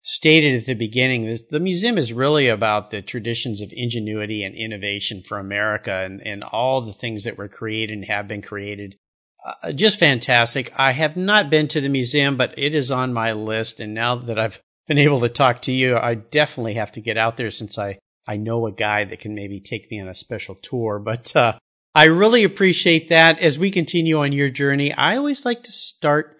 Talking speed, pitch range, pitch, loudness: 215 wpm, 105-150 Hz, 120 Hz, -19 LUFS